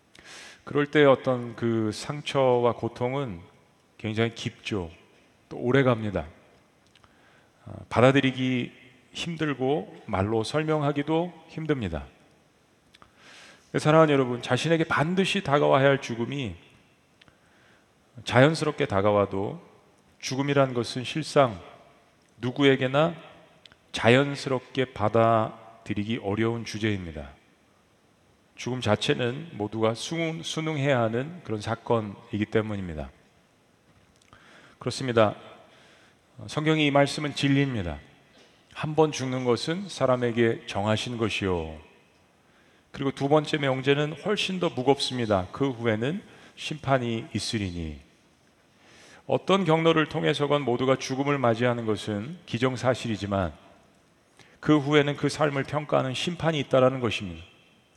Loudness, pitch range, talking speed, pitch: -26 LUFS, 110-145 Hz, 250 characters per minute, 125 Hz